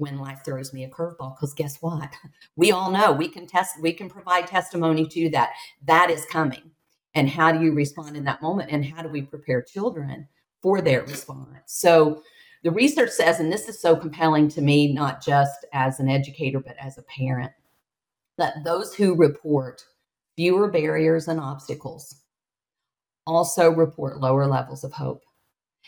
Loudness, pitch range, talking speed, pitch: -22 LUFS, 140-165 Hz, 175 wpm, 155 Hz